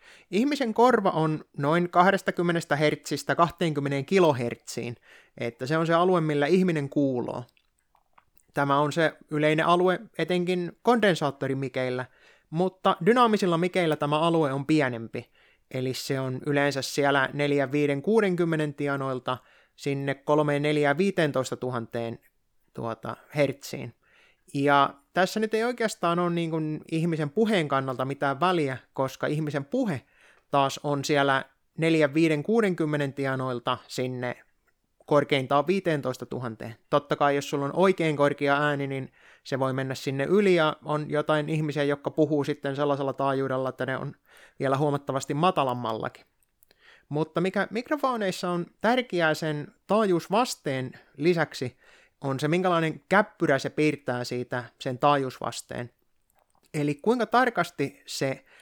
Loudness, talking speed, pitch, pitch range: -26 LUFS, 120 wpm, 150 Hz, 135-175 Hz